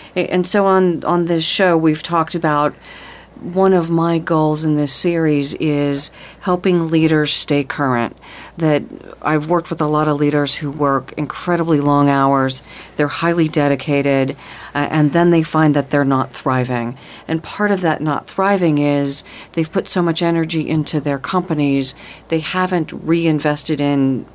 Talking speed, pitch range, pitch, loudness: 160 wpm, 145-170 Hz, 155 Hz, -17 LUFS